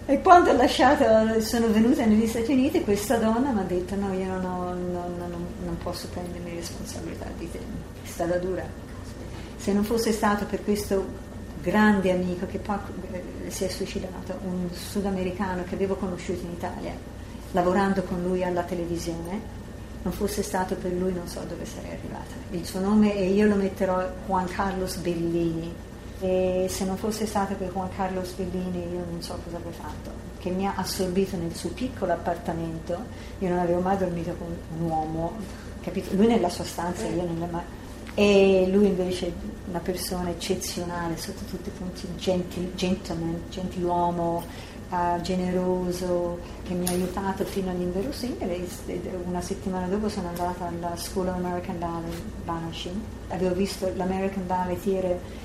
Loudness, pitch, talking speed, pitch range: -27 LUFS, 185 Hz, 160 wpm, 175-195 Hz